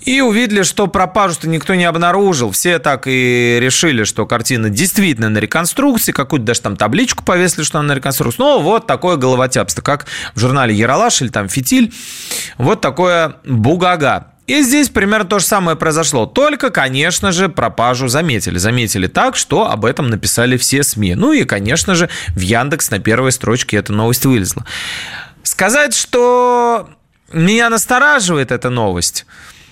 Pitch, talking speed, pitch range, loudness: 150 Hz, 155 wpm, 120-195 Hz, -13 LUFS